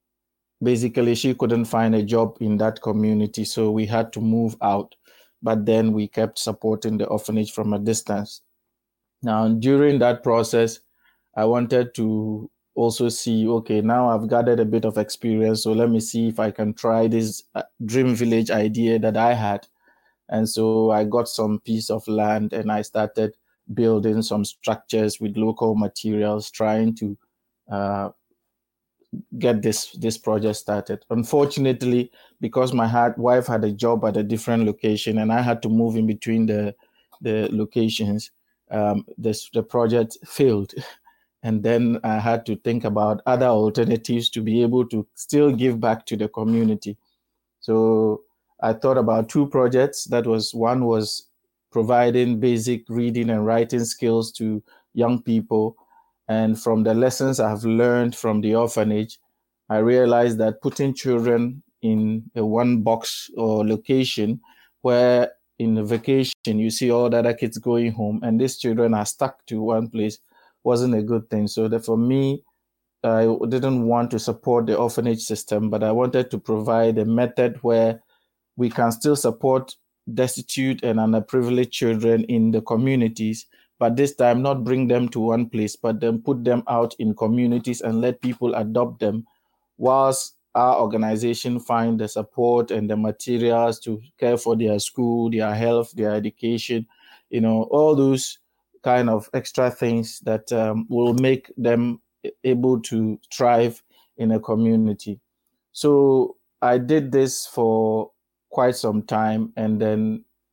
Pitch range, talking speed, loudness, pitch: 110-120 Hz, 160 wpm, -21 LUFS, 115 Hz